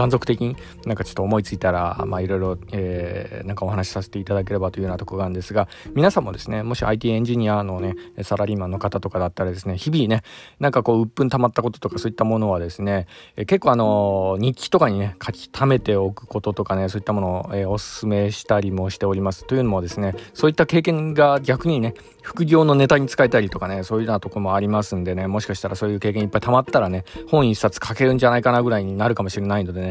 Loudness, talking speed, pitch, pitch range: -21 LUFS, 535 characters per minute, 105 Hz, 95-120 Hz